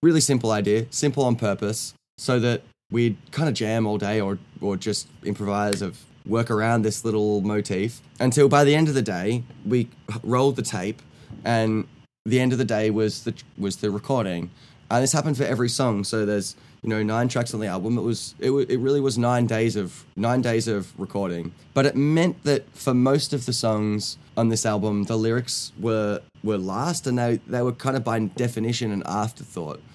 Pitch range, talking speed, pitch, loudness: 105-130 Hz, 200 wpm, 115 Hz, -24 LUFS